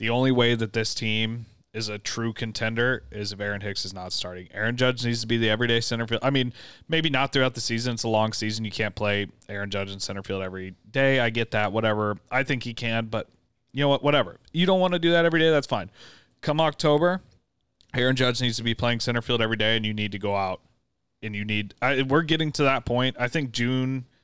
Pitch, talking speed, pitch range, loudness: 115 Hz, 250 wpm, 105-130 Hz, -25 LUFS